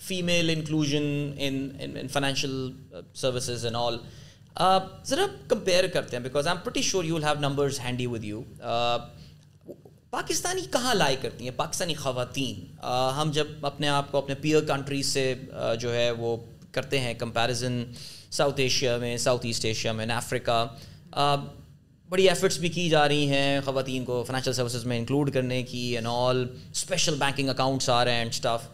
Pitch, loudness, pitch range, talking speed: 135 Hz, -27 LUFS, 120-150 Hz, 165 wpm